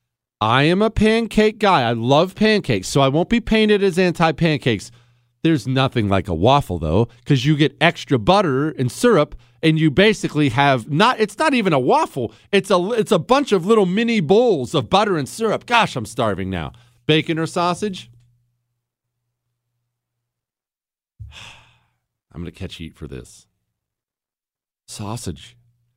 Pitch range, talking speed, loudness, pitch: 120-195 Hz, 150 wpm, -18 LUFS, 140 Hz